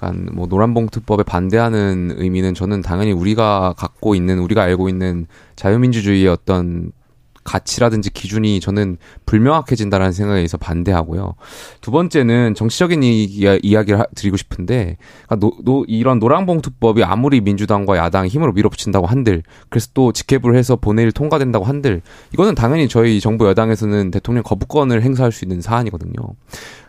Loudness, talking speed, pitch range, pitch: -16 LUFS, 405 characters per minute, 95-115 Hz, 105 Hz